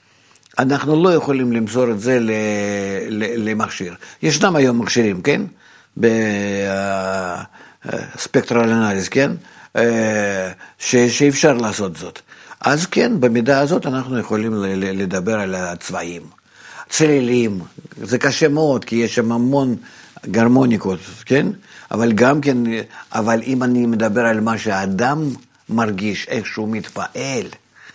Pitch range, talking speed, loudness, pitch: 100-125 Hz, 105 wpm, -18 LUFS, 115 Hz